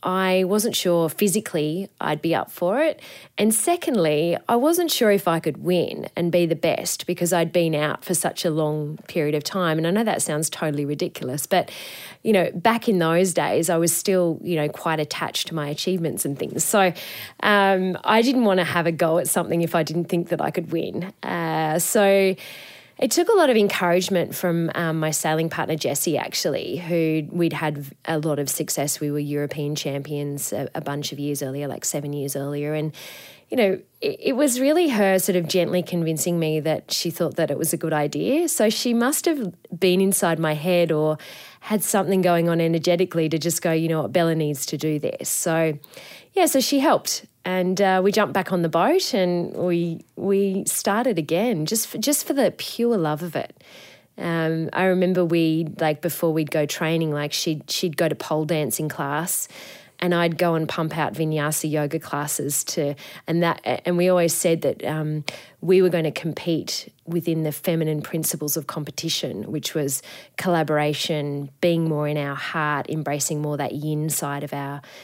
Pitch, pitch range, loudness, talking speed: 165 Hz, 155-185 Hz, -22 LUFS, 200 wpm